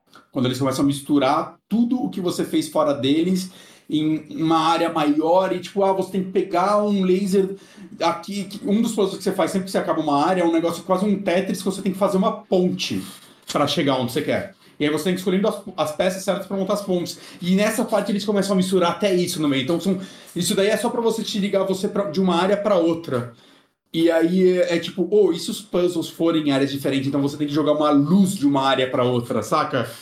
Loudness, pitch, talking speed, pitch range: -21 LUFS, 185 Hz, 250 wpm, 160-200 Hz